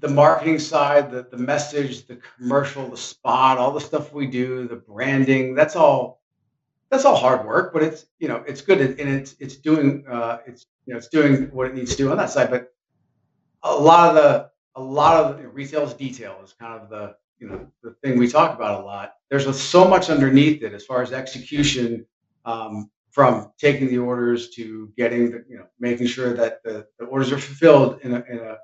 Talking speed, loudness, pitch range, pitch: 215 wpm, -19 LUFS, 120-145 Hz, 130 Hz